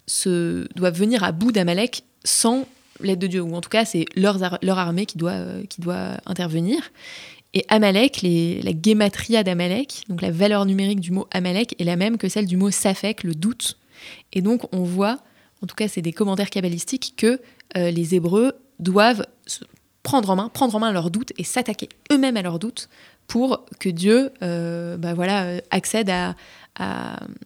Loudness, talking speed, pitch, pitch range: -22 LUFS, 190 wpm, 195 Hz, 180-225 Hz